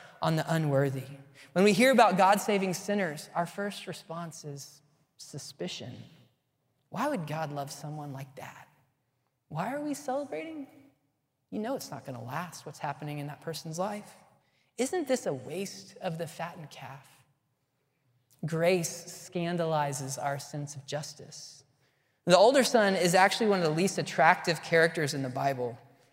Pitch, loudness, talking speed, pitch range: 155 Hz, -29 LUFS, 150 wpm, 140-185 Hz